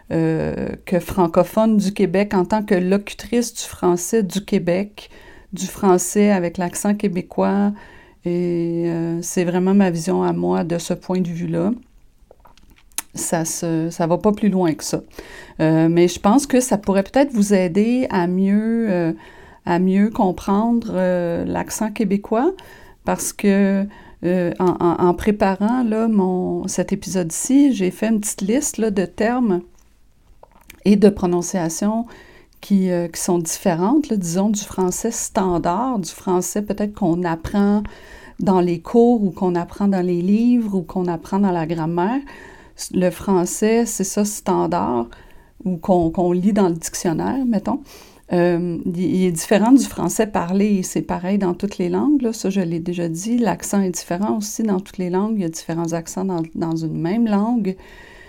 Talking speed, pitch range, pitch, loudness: 165 wpm, 175-210 Hz, 190 Hz, -19 LUFS